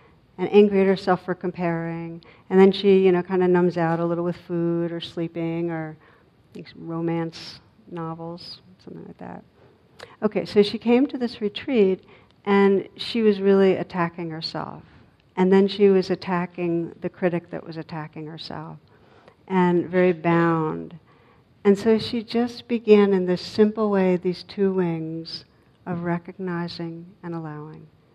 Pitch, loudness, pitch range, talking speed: 180 Hz, -22 LUFS, 165-195 Hz, 150 wpm